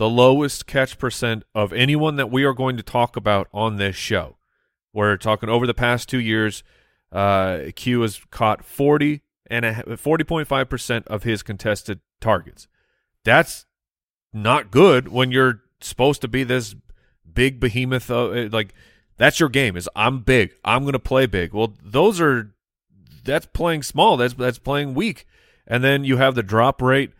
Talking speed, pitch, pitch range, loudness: 170 wpm, 120 Hz, 110-130 Hz, -20 LUFS